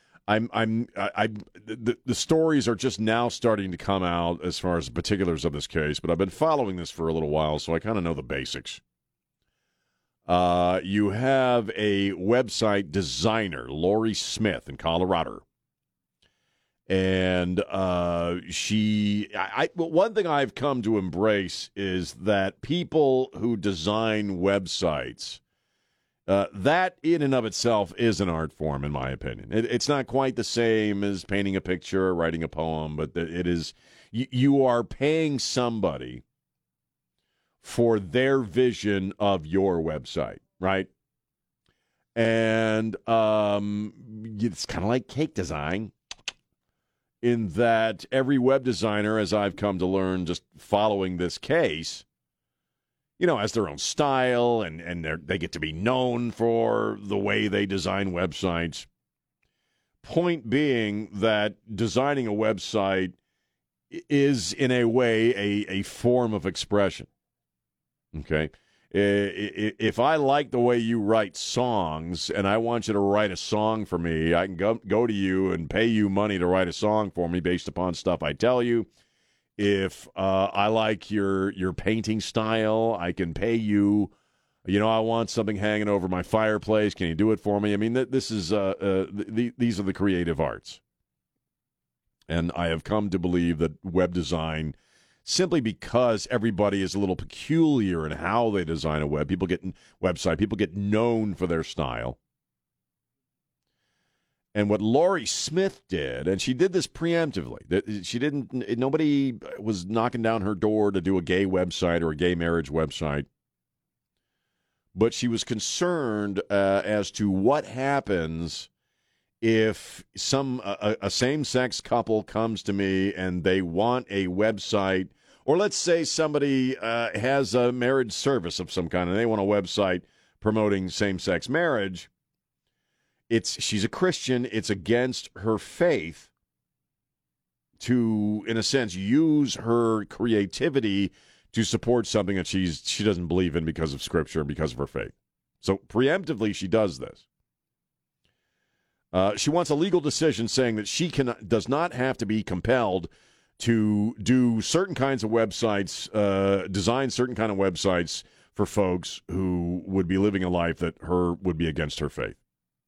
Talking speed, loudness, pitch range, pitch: 160 wpm, -26 LUFS, 90-115 Hz, 105 Hz